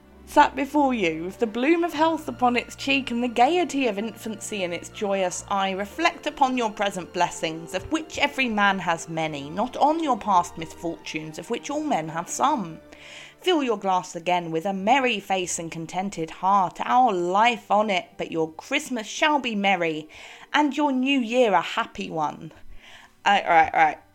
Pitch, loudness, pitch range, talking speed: 220 Hz, -24 LUFS, 180-275 Hz, 190 wpm